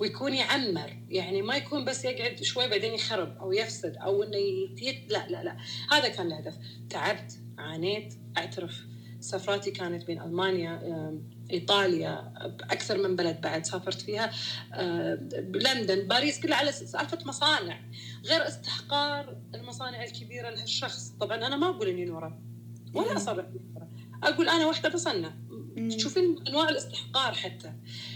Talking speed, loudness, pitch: 135 wpm, -30 LUFS, 170 Hz